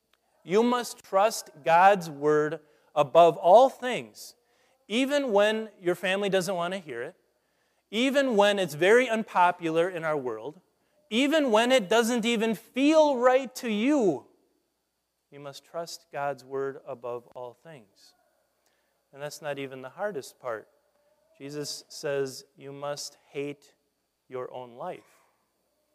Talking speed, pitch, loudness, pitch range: 130 wpm, 185 Hz, -25 LUFS, 145-235 Hz